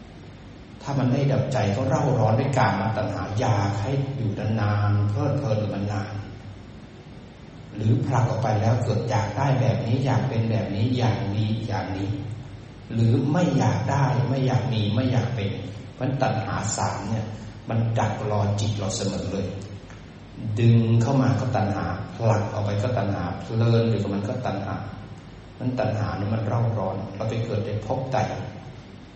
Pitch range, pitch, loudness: 100-125 Hz, 110 Hz, -24 LUFS